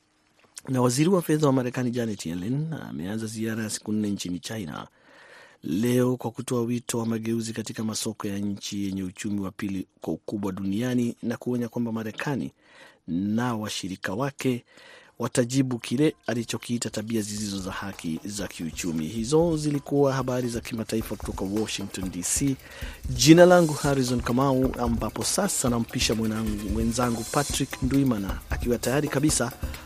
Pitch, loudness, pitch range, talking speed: 115 Hz, -26 LUFS, 105-130 Hz, 135 wpm